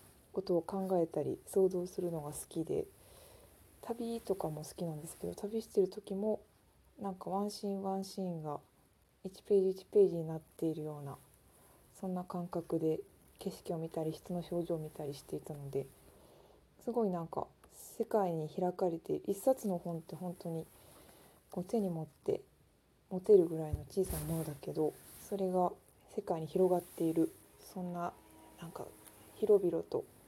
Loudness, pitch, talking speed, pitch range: -37 LUFS, 180 Hz, 305 characters per minute, 160-195 Hz